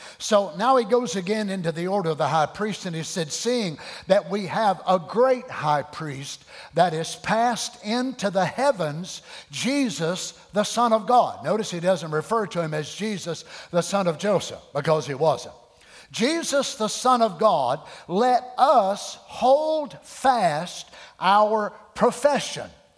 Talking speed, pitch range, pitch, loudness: 155 wpm, 170-240 Hz, 200 Hz, -23 LUFS